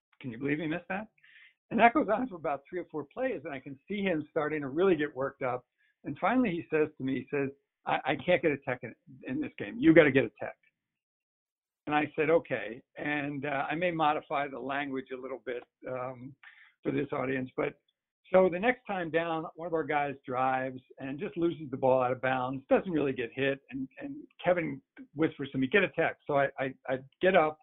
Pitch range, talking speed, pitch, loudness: 135-180 Hz, 230 wpm, 150 Hz, -31 LUFS